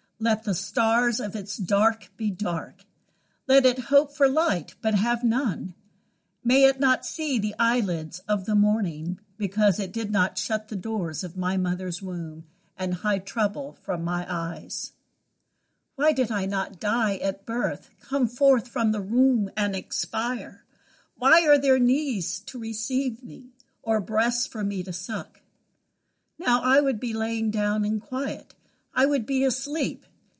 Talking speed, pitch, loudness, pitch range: 160 wpm, 220 Hz, -25 LUFS, 195-255 Hz